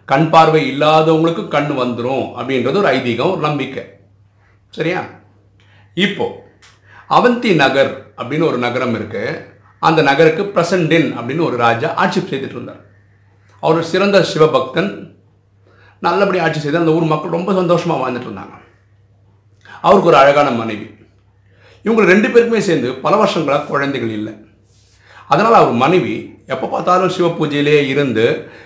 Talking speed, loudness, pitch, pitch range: 105 wpm, -14 LUFS, 135 Hz, 105-165 Hz